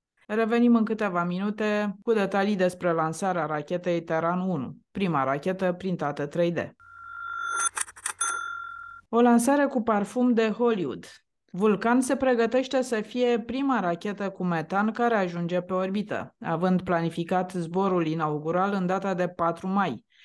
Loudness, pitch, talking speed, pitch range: -26 LUFS, 200 Hz, 125 wpm, 175-240 Hz